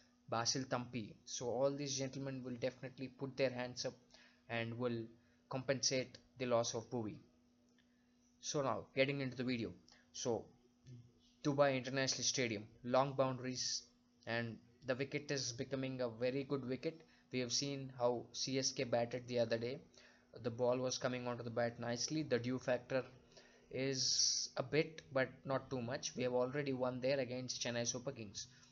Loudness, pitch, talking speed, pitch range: -40 LUFS, 125 Hz, 160 wpm, 120-135 Hz